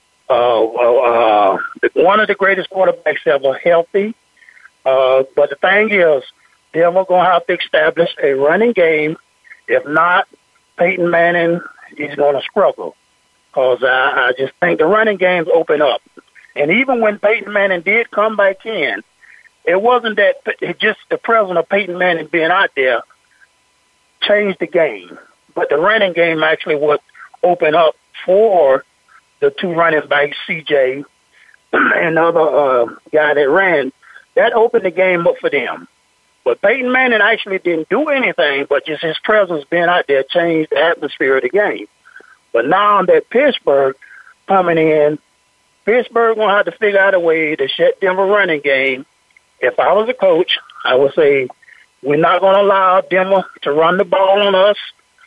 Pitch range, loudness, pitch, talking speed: 160-225 Hz, -14 LUFS, 190 Hz, 170 wpm